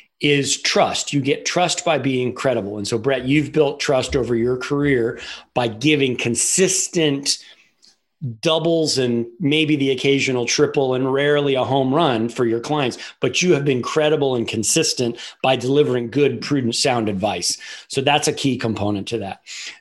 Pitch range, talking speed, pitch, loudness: 120-145 Hz, 165 wpm, 135 Hz, -19 LUFS